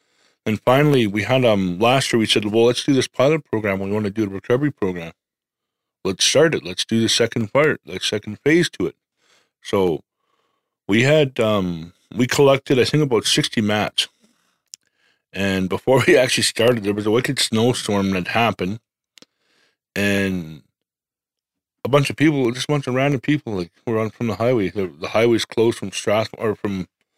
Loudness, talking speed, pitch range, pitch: -19 LUFS, 185 wpm, 100-125 Hz, 110 Hz